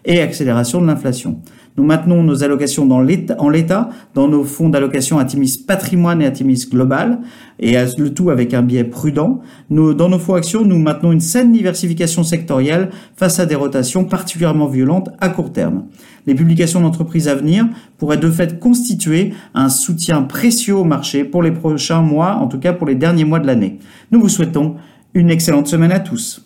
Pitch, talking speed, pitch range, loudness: 165 Hz, 190 wpm, 140-185 Hz, -14 LUFS